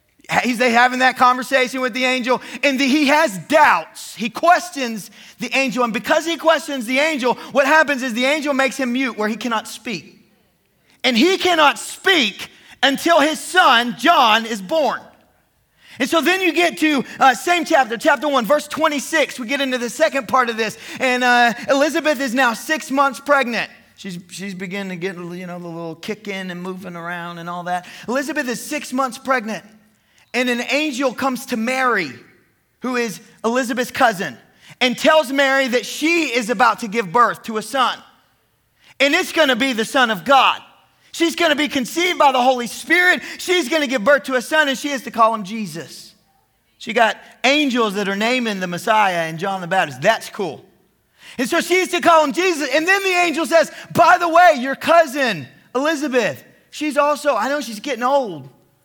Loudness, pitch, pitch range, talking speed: -17 LUFS, 260 Hz, 230-300 Hz, 190 wpm